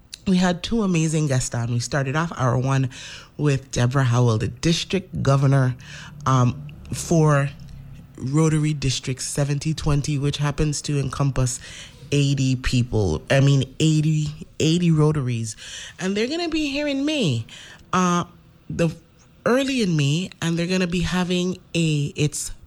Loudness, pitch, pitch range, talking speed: -22 LUFS, 150 Hz, 135-170 Hz, 140 wpm